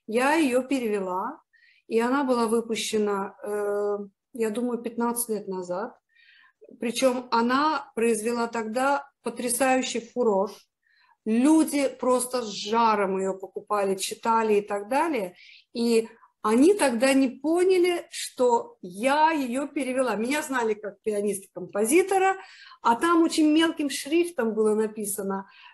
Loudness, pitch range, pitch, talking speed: -25 LUFS, 215-280 Hz, 235 Hz, 115 wpm